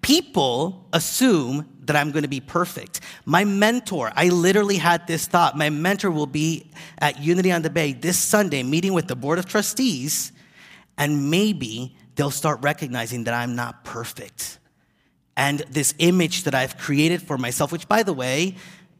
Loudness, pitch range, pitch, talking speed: -21 LUFS, 145-180 Hz, 165 Hz, 165 wpm